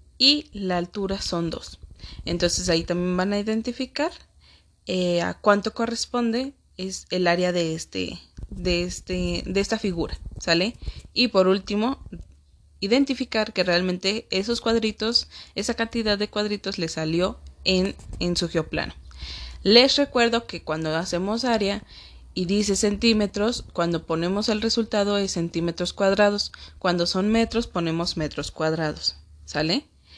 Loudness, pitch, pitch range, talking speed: -24 LUFS, 185 Hz, 165-220 Hz, 135 wpm